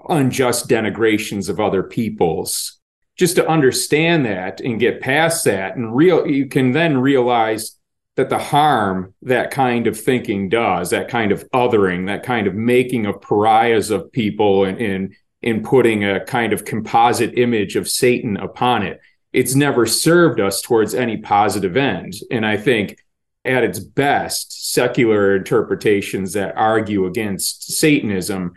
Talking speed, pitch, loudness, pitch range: 150 wpm, 115 Hz, -17 LUFS, 100-130 Hz